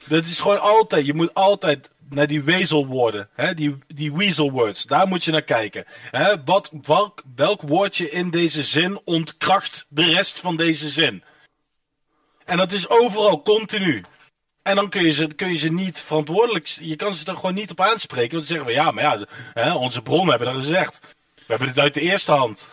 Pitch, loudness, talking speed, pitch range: 150 Hz, -20 LUFS, 200 wpm, 150-180 Hz